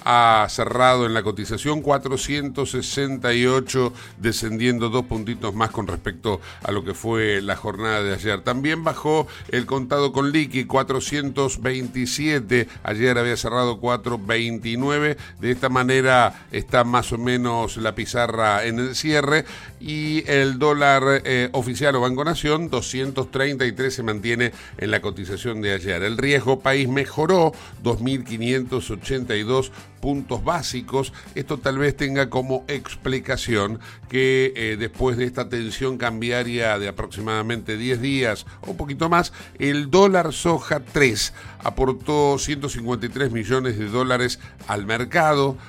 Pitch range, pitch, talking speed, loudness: 115-135 Hz, 125 Hz, 130 wpm, -22 LUFS